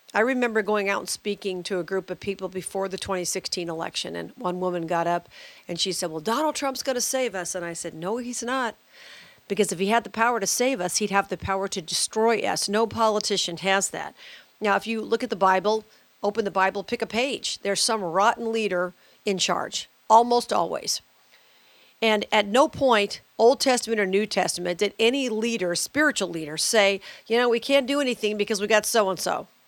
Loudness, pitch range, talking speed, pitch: -24 LUFS, 185-230 Hz, 210 wpm, 205 Hz